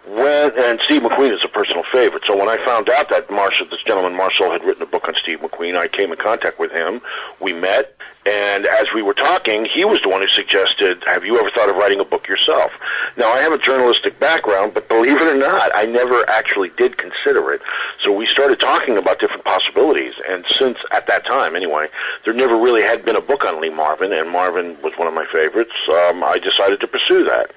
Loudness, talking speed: -16 LUFS, 230 wpm